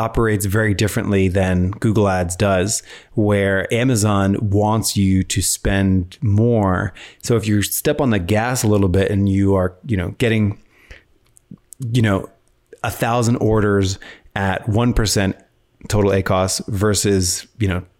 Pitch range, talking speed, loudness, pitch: 95-110 Hz, 145 wpm, -18 LUFS, 100 Hz